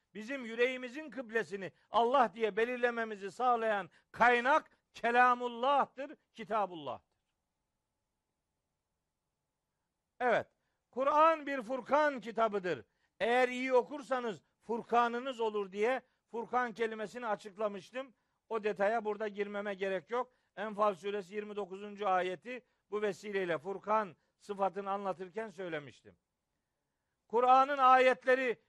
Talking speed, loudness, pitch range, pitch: 90 wpm, -33 LUFS, 205-250 Hz, 225 Hz